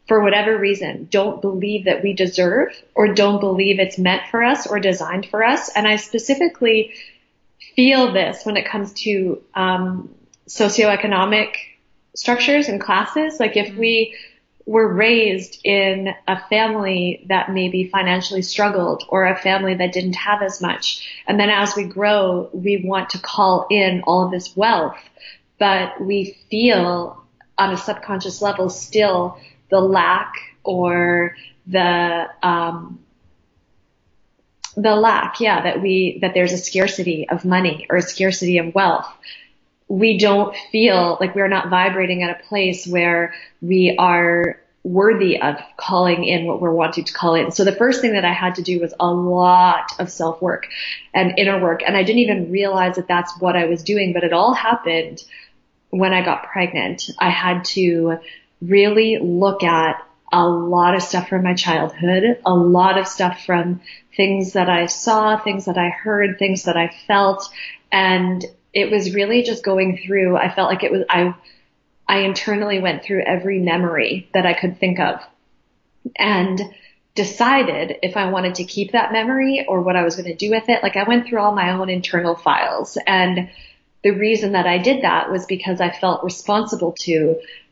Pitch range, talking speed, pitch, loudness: 180-205 Hz, 170 wpm, 190 Hz, -17 LUFS